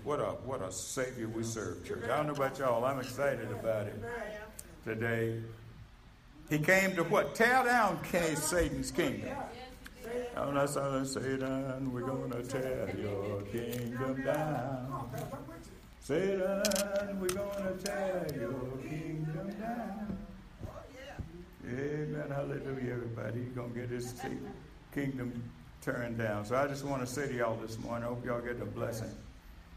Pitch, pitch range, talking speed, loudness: 130 Hz, 120-155 Hz, 145 wpm, -35 LUFS